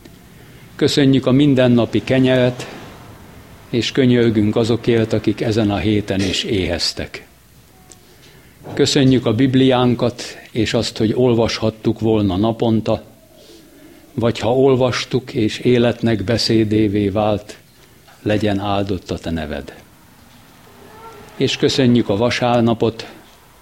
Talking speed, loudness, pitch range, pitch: 95 wpm, -17 LUFS, 105-125 Hz, 115 Hz